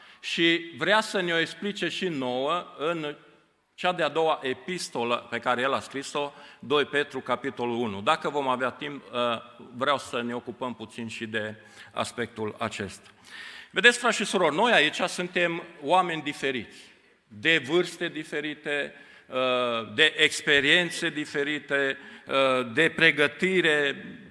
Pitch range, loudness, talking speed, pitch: 125-170 Hz, -26 LUFS, 130 wpm, 145 Hz